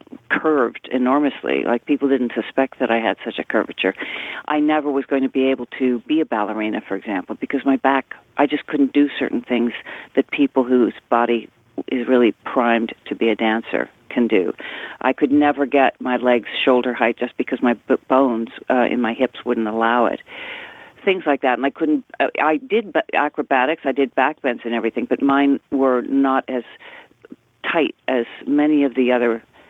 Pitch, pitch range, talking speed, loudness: 130 Hz, 120-145 Hz, 190 wpm, -19 LUFS